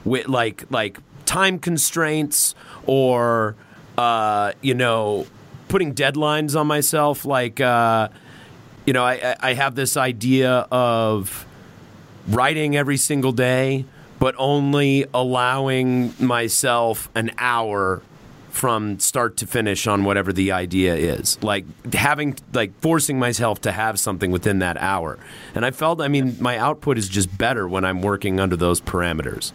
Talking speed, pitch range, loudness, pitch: 140 wpm, 110-140 Hz, -20 LUFS, 125 Hz